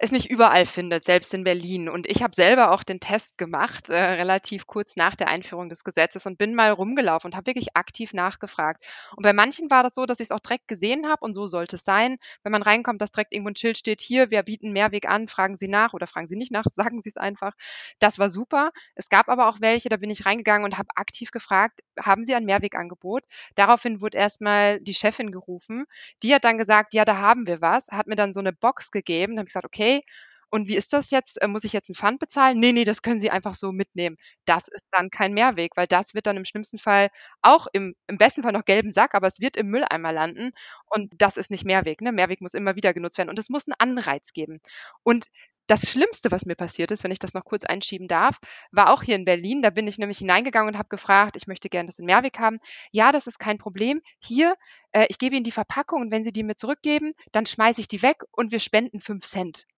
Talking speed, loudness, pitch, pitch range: 250 wpm, -22 LUFS, 210 Hz, 190-235 Hz